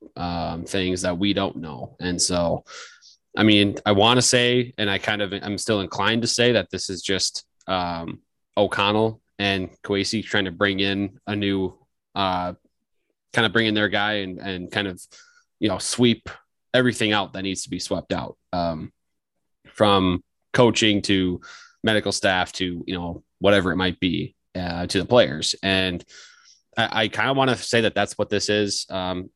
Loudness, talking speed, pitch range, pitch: -22 LUFS, 185 wpm, 90-110 Hz, 100 Hz